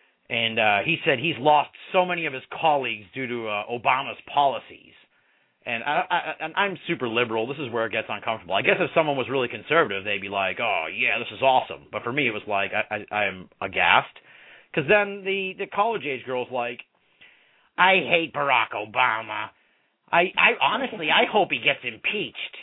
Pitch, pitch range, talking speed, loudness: 125 Hz, 105-165 Hz, 200 wpm, -23 LUFS